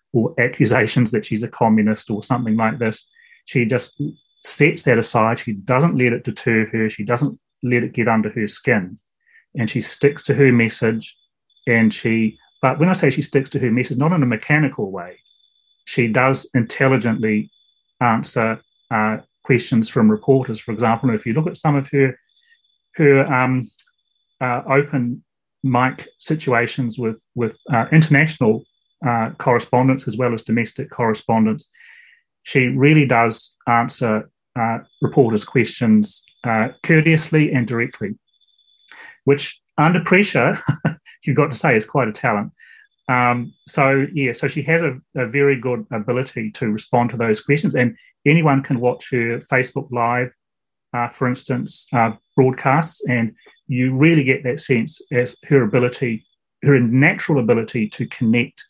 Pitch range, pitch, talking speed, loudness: 115-140 Hz, 125 Hz, 155 wpm, -18 LUFS